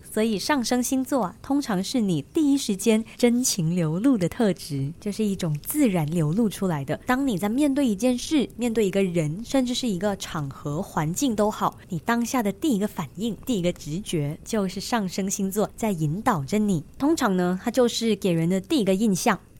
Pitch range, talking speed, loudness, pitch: 180-245 Hz, 295 characters per minute, -24 LUFS, 210 Hz